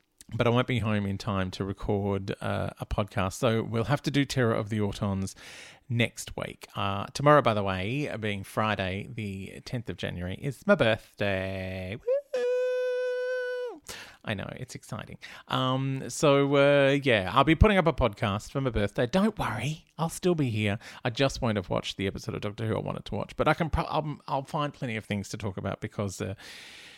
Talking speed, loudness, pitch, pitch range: 200 wpm, -28 LUFS, 115 Hz, 100-140 Hz